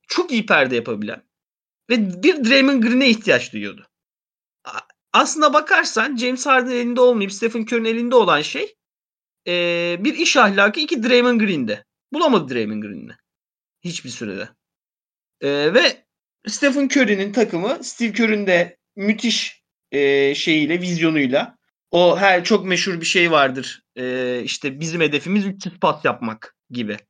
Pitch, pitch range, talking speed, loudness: 205 Hz, 165-250 Hz, 125 wpm, -18 LUFS